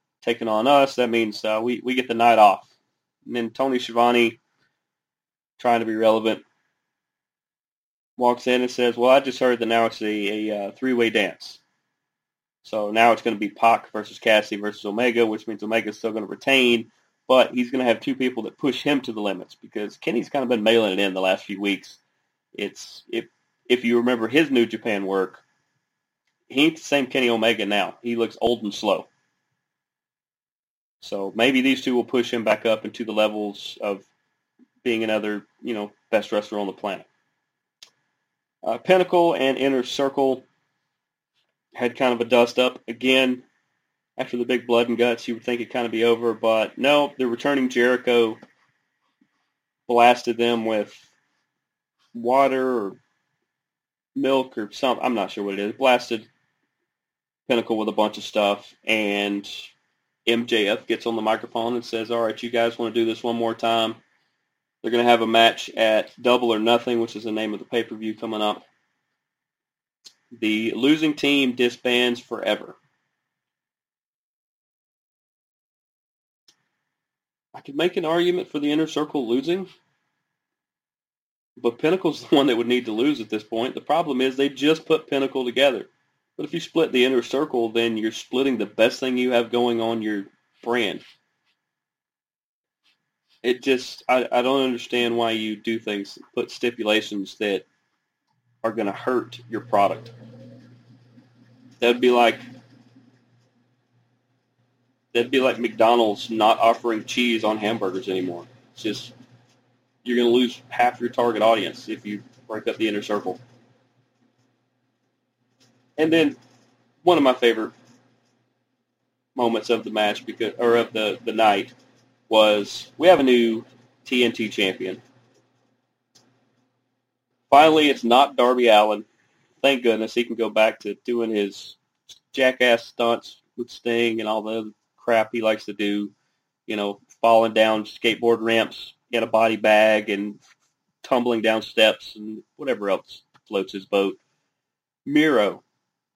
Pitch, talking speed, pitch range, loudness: 120 Hz, 160 wpm, 110-125 Hz, -22 LUFS